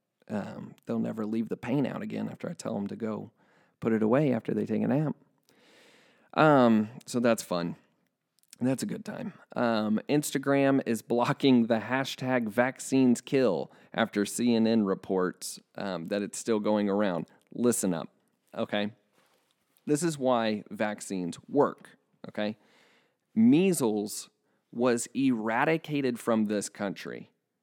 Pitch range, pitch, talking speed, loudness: 105-135 Hz, 115 Hz, 135 wpm, -29 LUFS